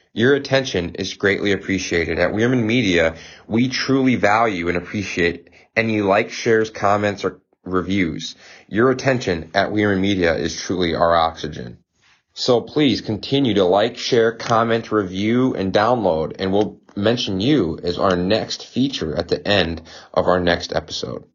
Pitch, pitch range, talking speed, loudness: 100 Hz, 90-115 Hz, 150 wpm, -19 LUFS